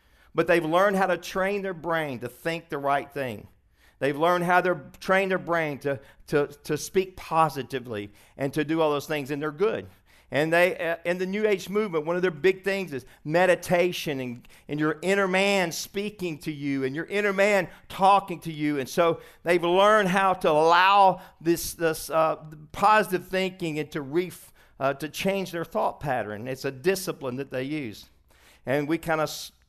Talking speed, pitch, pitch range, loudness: 195 wpm, 165 Hz, 140-185 Hz, -25 LUFS